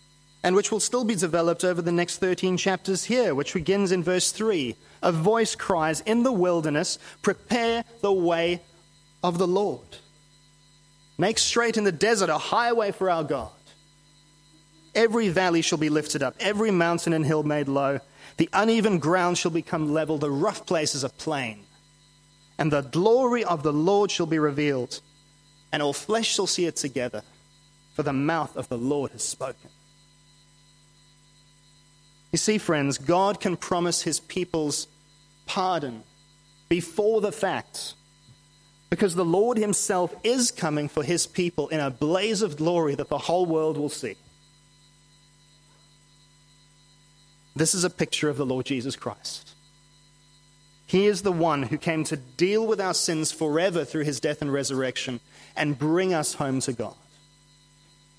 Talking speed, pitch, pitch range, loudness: 155 wpm, 155 Hz, 145-180 Hz, -25 LUFS